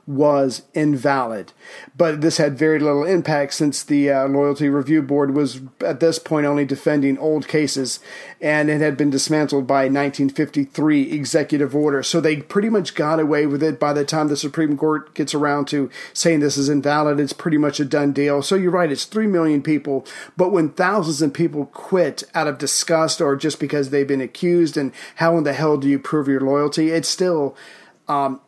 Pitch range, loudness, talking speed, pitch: 140-160 Hz, -19 LUFS, 195 wpm, 150 Hz